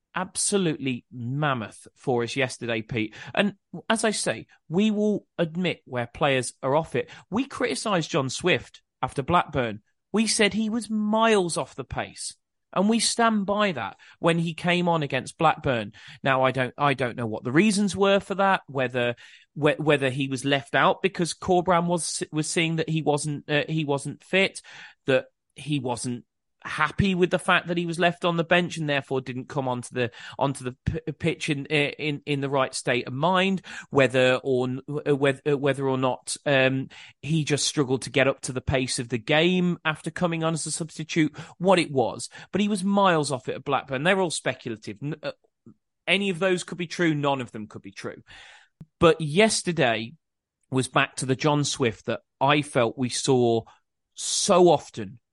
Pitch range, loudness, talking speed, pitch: 130-175 Hz, -25 LUFS, 190 wpm, 150 Hz